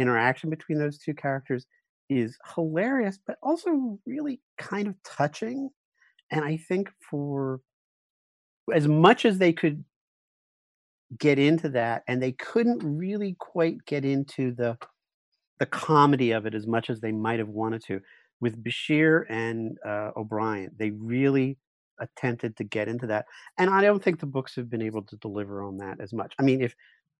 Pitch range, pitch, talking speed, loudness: 115-165 Hz, 135 Hz, 165 wpm, -27 LUFS